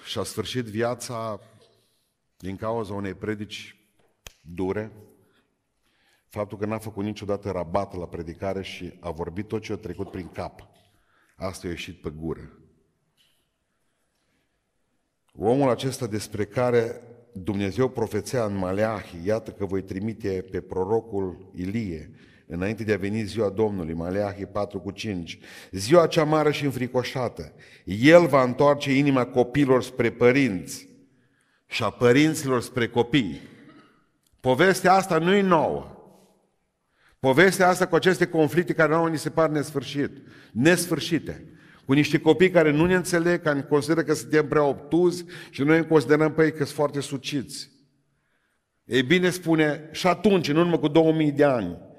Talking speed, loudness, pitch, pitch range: 145 wpm, -24 LUFS, 120 Hz, 100-155 Hz